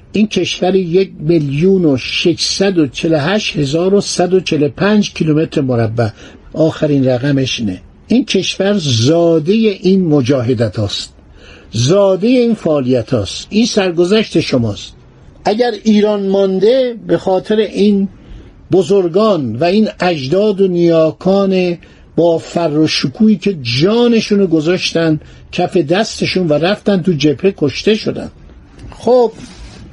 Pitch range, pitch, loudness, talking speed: 150-200 Hz, 180 Hz, -13 LUFS, 95 wpm